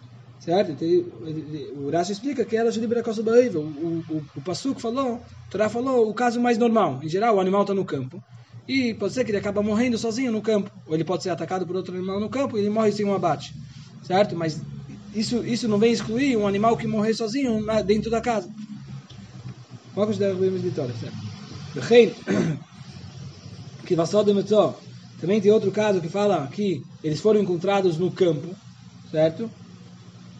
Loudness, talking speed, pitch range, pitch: -23 LUFS, 185 wpm, 155-220 Hz, 195 Hz